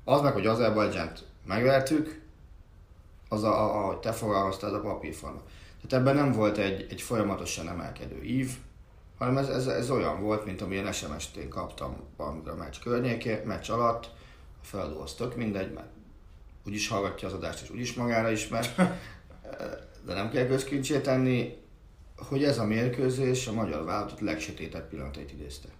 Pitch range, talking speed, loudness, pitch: 85-120 Hz, 160 wpm, -30 LUFS, 105 Hz